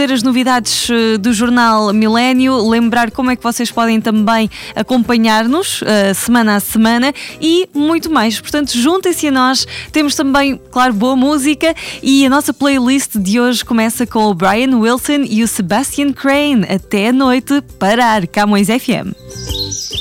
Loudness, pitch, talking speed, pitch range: -12 LUFS, 245 Hz, 150 wpm, 220-275 Hz